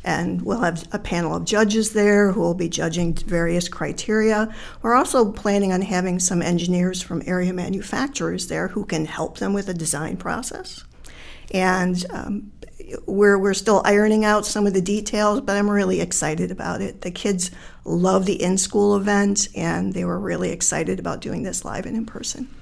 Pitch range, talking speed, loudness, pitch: 180-210 Hz, 185 wpm, -21 LUFS, 195 Hz